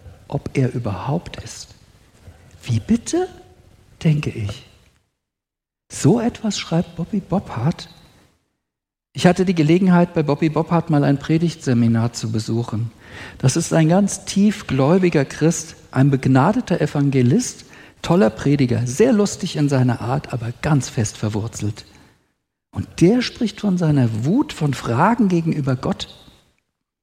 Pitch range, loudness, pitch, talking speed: 115-170 Hz, -19 LUFS, 140 Hz, 120 wpm